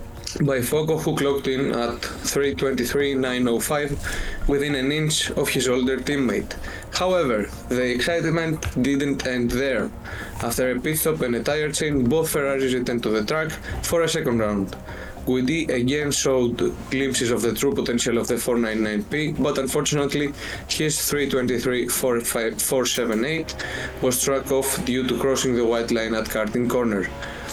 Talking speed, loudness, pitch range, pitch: 140 wpm, -23 LUFS, 120-140 Hz, 130 Hz